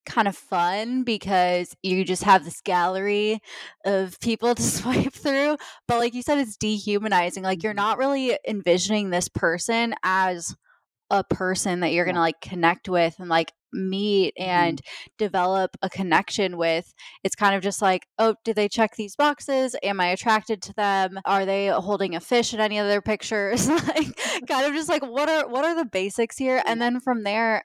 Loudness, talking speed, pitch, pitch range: -23 LUFS, 185 wpm, 205 Hz, 185-235 Hz